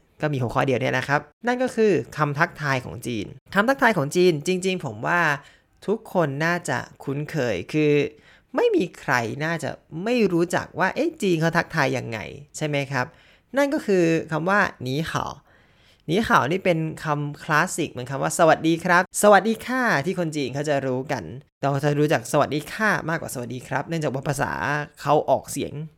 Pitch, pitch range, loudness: 155 Hz, 140-180 Hz, -23 LUFS